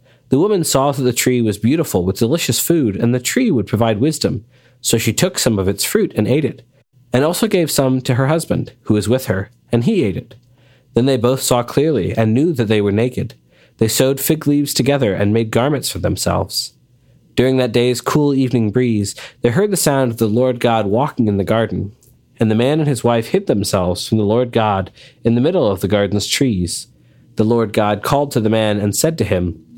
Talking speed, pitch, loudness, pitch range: 225 wpm, 120 Hz, -16 LUFS, 110-130 Hz